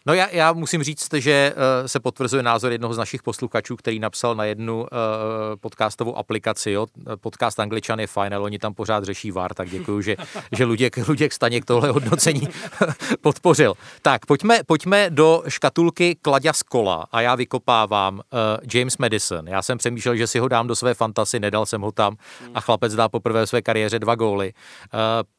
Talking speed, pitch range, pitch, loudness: 175 wpm, 110-140 Hz, 115 Hz, -21 LUFS